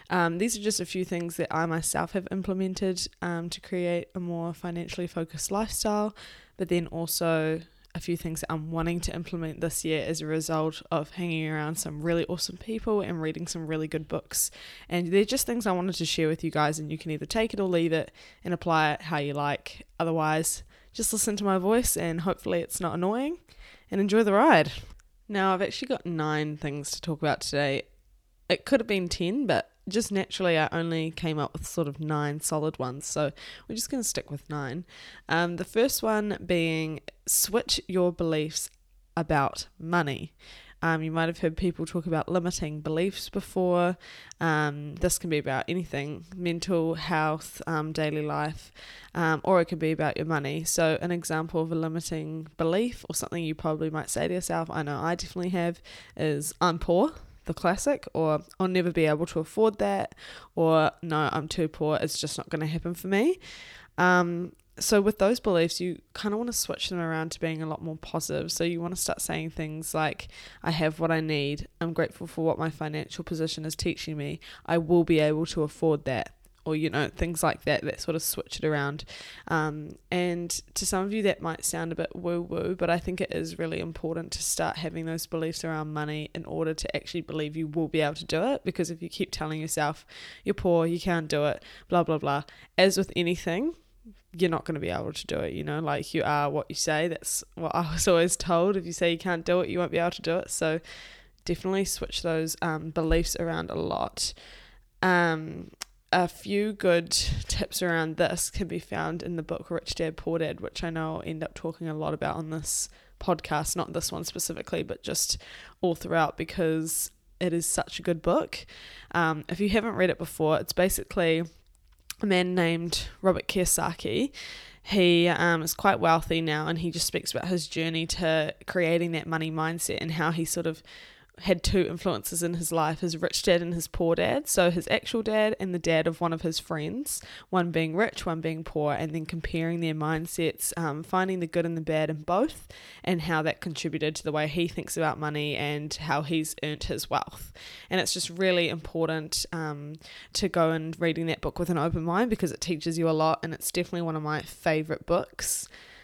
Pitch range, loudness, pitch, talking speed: 155-180 Hz, -28 LUFS, 165 Hz, 210 wpm